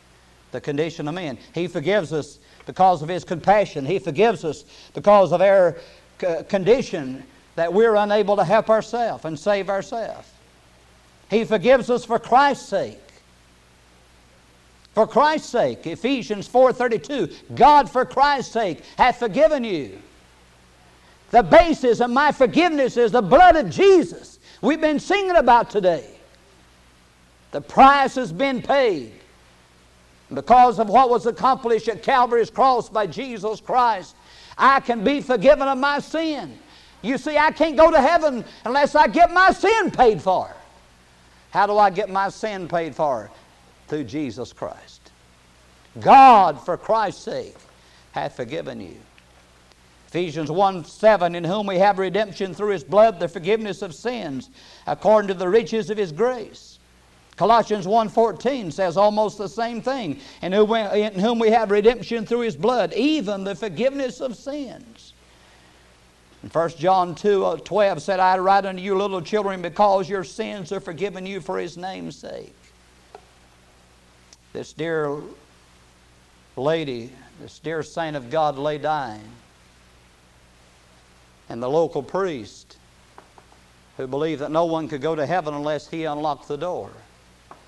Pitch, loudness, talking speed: 190 Hz, -20 LUFS, 140 wpm